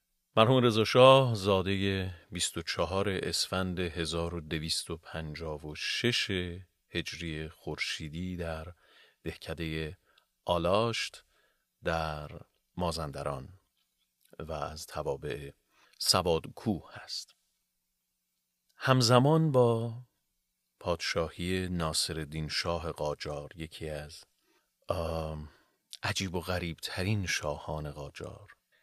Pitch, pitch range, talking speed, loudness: 85 Hz, 80-95 Hz, 65 wpm, -31 LUFS